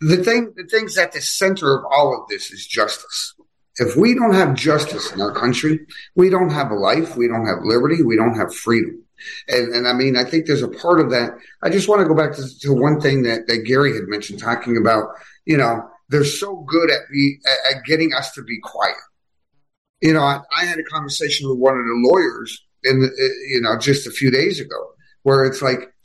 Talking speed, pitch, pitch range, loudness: 230 wpm, 140 Hz, 125-165 Hz, -18 LUFS